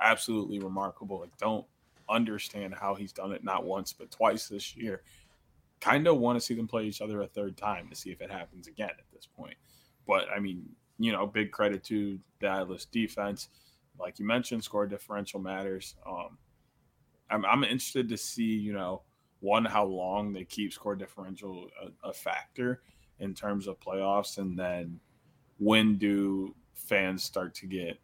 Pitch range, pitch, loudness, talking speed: 95-110 Hz, 100 Hz, -32 LUFS, 175 wpm